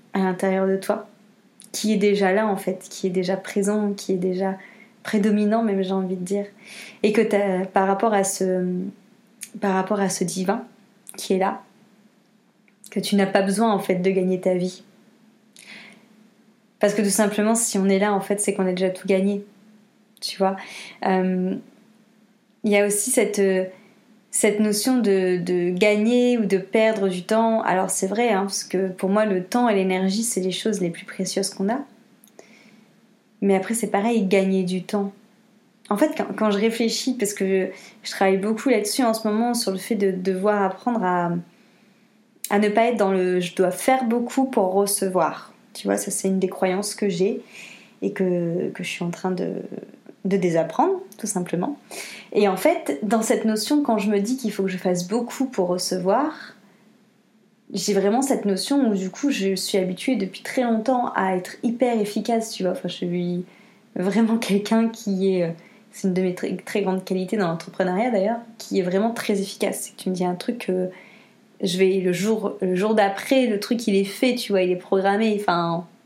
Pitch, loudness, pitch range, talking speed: 205 Hz, -22 LUFS, 190-220 Hz, 200 wpm